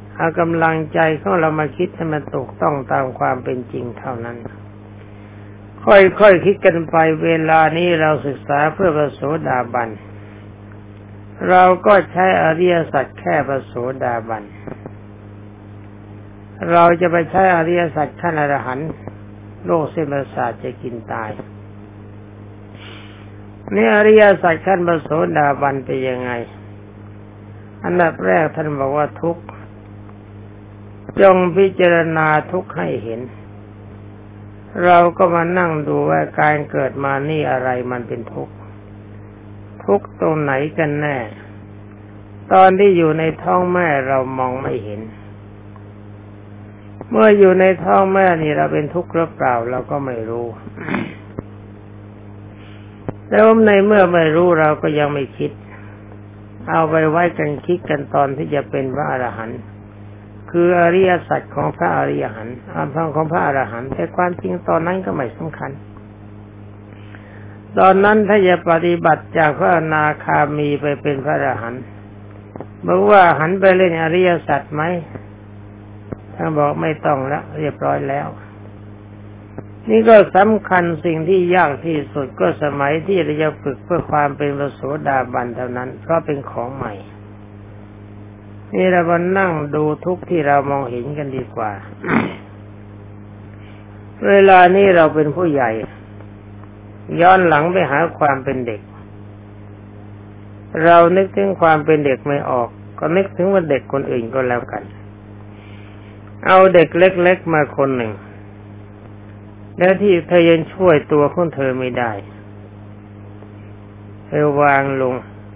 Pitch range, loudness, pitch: 105-160 Hz, -15 LUFS, 130 Hz